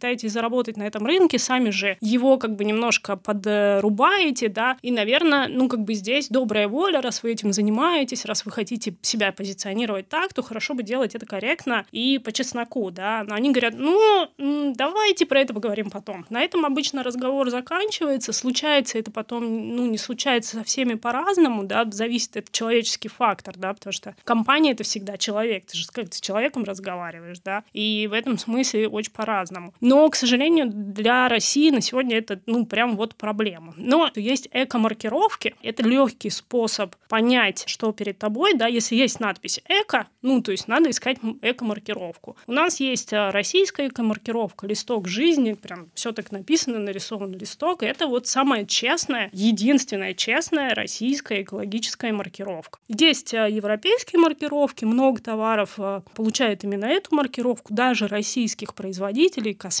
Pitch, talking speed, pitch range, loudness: 230 Hz, 160 wpm, 210-265 Hz, -22 LUFS